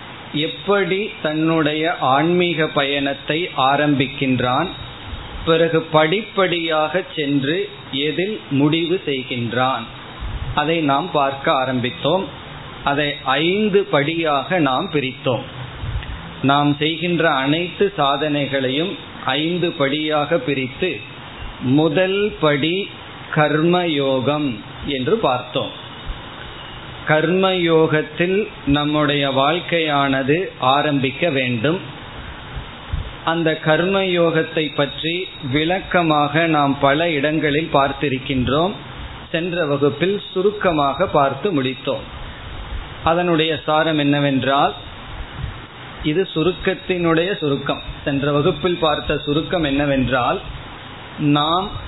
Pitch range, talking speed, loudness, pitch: 135-165 Hz, 70 wpm, -19 LUFS, 150 Hz